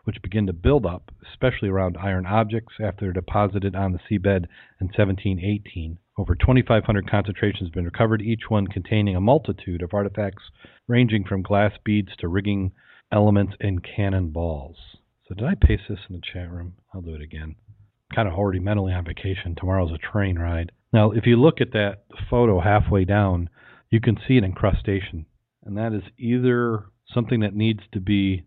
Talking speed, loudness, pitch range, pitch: 190 wpm, -23 LUFS, 90-110 Hz, 100 Hz